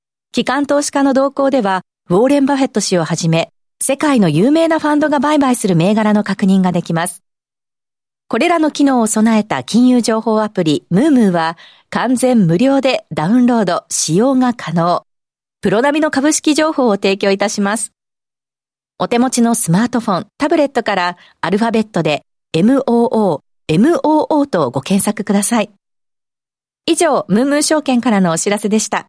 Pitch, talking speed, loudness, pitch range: 225 Hz, 340 characters per minute, -14 LUFS, 190-270 Hz